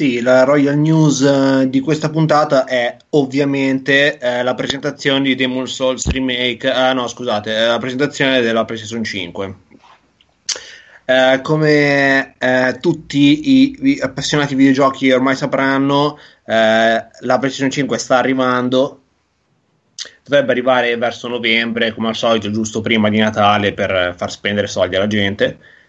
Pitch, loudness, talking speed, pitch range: 130 Hz, -15 LUFS, 130 wpm, 115-140 Hz